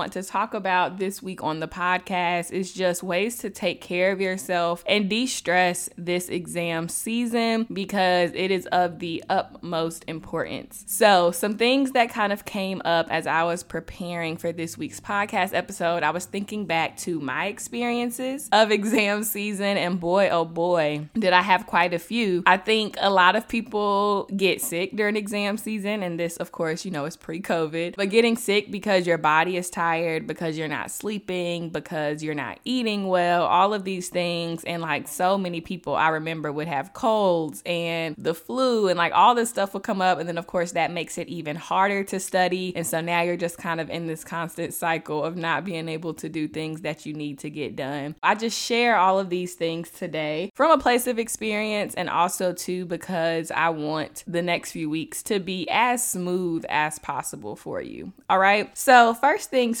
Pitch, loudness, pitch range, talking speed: 180 Hz, -24 LUFS, 165-205 Hz, 200 wpm